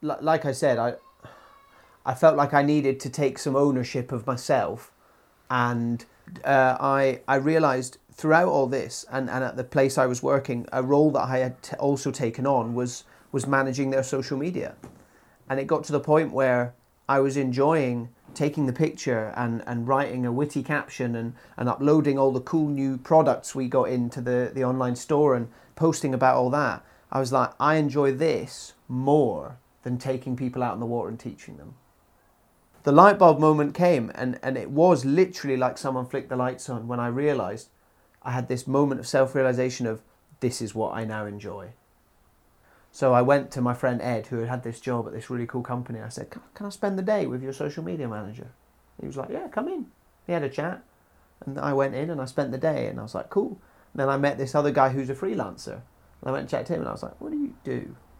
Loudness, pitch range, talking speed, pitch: -25 LUFS, 125-145 Hz, 220 wpm, 135 Hz